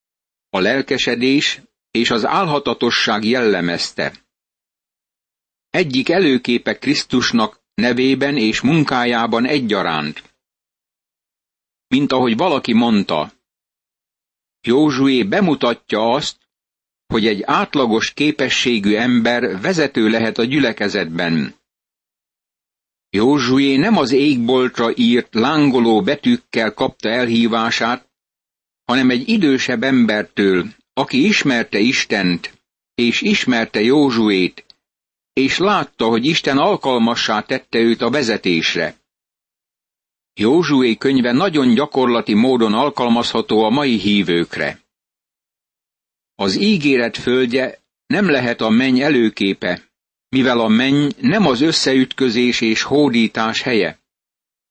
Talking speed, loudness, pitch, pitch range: 90 wpm, -16 LUFS, 125 Hz, 115-140 Hz